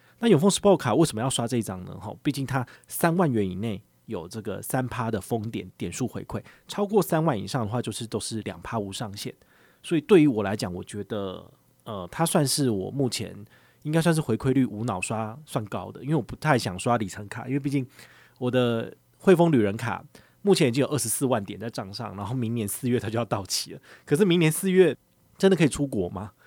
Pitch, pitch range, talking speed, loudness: 120 Hz, 110-145 Hz, 330 characters per minute, -26 LUFS